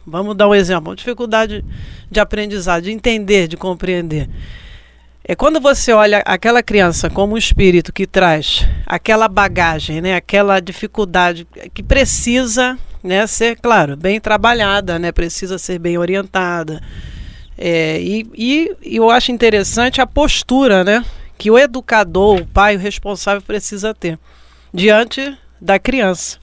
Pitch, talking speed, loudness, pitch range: 200 Hz, 140 wpm, -14 LUFS, 175-225 Hz